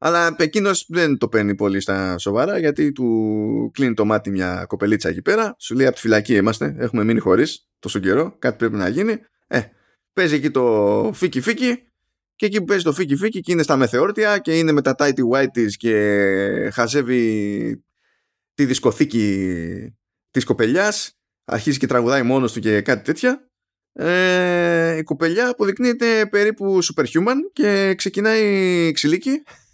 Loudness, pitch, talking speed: -19 LUFS, 145 Hz, 155 wpm